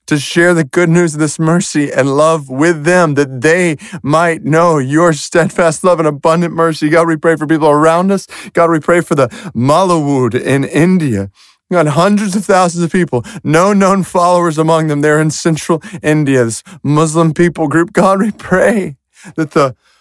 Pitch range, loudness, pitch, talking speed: 150-175 Hz, -11 LUFS, 165 Hz, 185 wpm